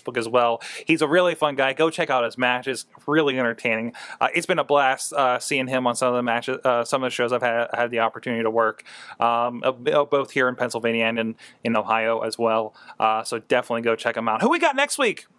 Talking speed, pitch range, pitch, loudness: 240 wpm, 115-135 Hz, 125 Hz, -22 LUFS